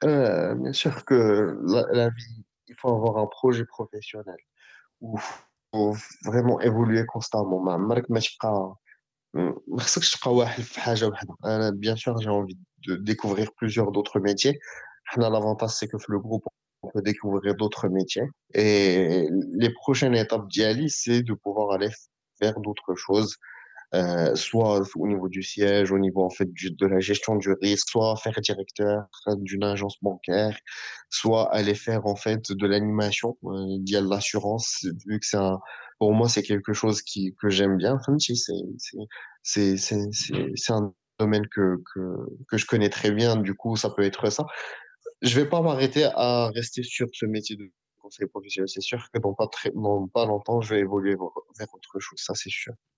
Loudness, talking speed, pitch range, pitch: -25 LUFS, 175 wpm, 100-115 Hz, 105 Hz